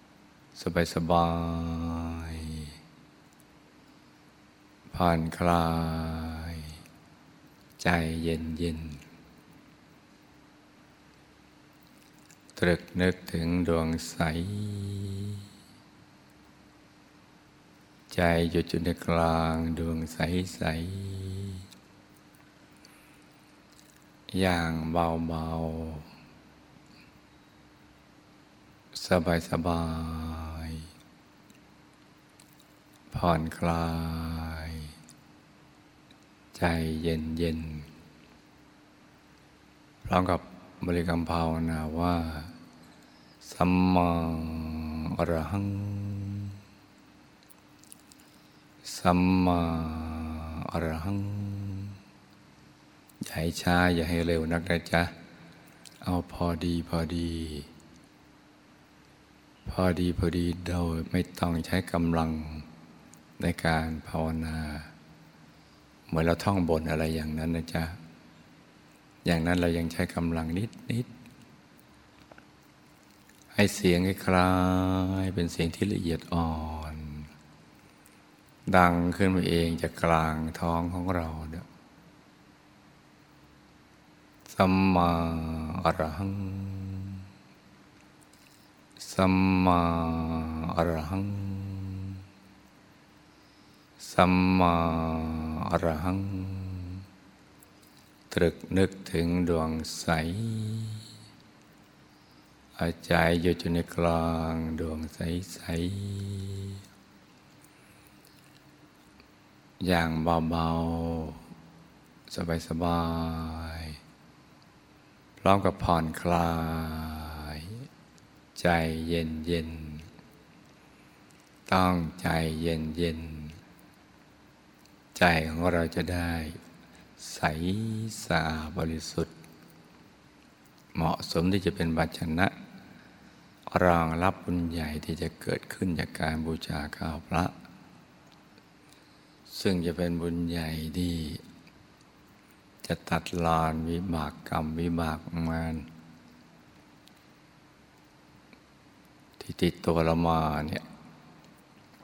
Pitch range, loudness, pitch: 80-90 Hz, -29 LUFS, 85 Hz